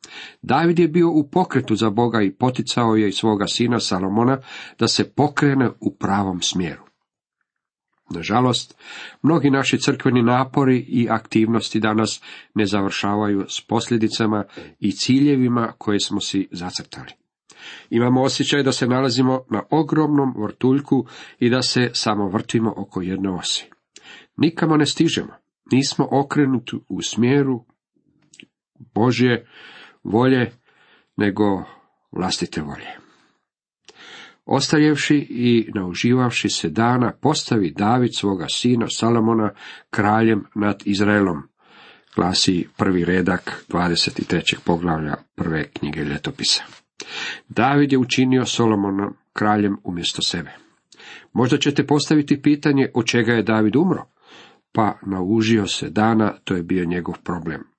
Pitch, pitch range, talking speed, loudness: 115 Hz, 100-130 Hz, 115 wpm, -20 LUFS